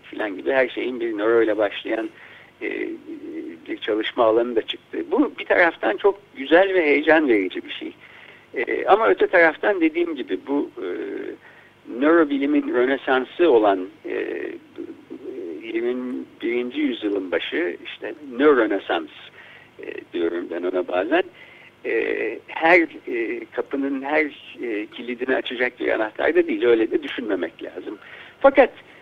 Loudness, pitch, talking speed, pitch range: -21 LUFS, 345 Hz, 130 wpm, 265-380 Hz